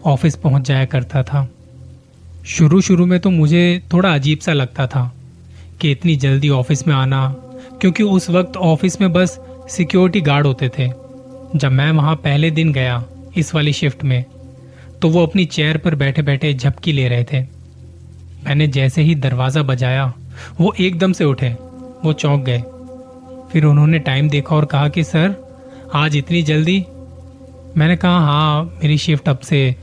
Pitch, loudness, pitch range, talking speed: 145 Hz, -15 LUFS, 130-165 Hz, 165 wpm